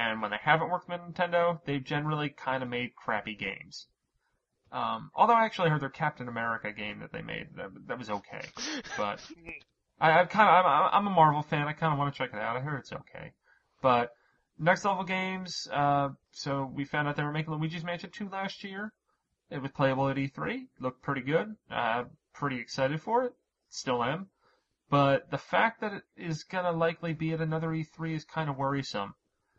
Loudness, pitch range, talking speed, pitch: -30 LUFS, 135-175 Hz, 200 wpm, 150 Hz